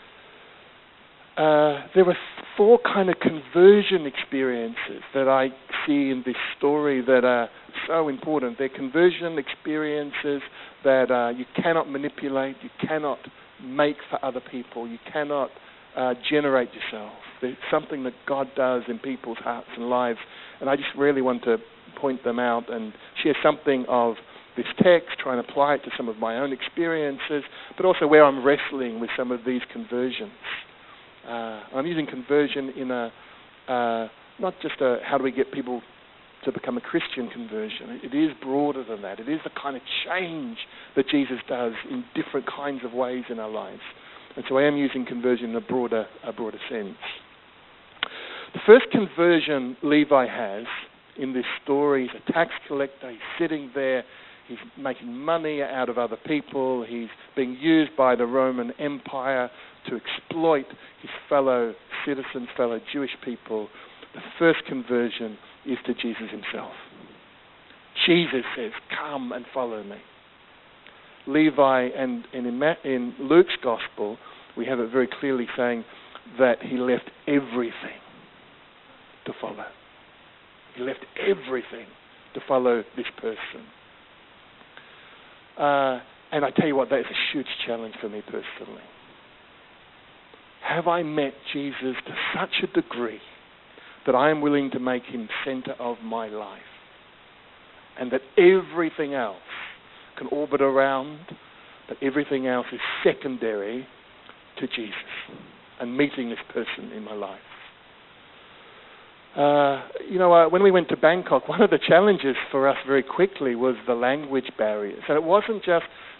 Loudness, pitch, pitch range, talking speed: -24 LUFS, 135 Hz, 125-150 Hz, 150 wpm